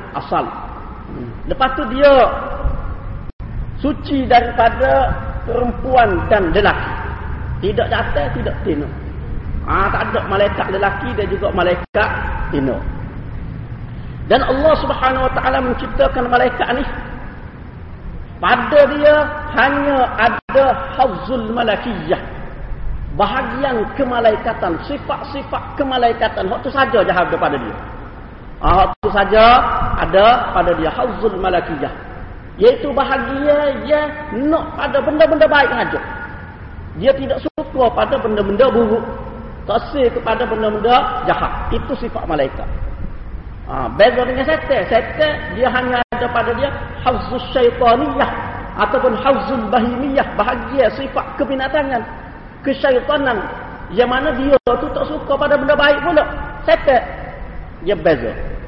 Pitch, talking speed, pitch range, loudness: 260 Hz, 115 wpm, 235-285 Hz, -16 LUFS